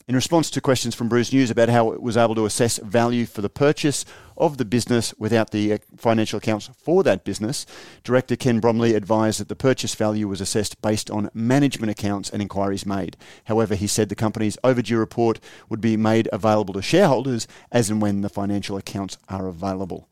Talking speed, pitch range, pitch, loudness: 195 wpm, 105-120 Hz, 110 Hz, -22 LUFS